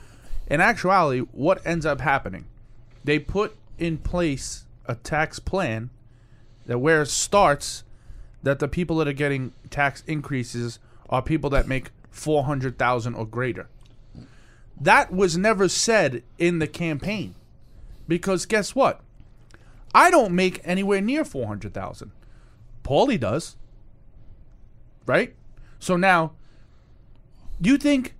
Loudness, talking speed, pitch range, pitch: -23 LUFS, 125 wpm, 115-175 Hz, 135 Hz